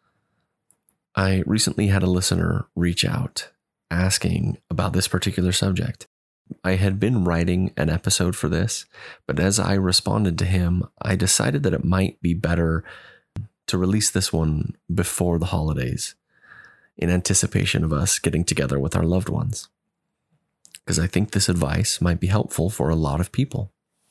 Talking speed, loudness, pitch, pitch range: 155 wpm, -22 LUFS, 90 Hz, 85-100 Hz